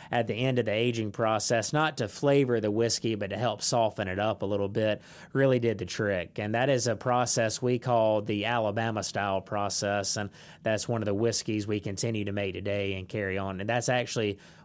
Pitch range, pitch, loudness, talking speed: 100-120 Hz, 110 Hz, -28 LUFS, 215 wpm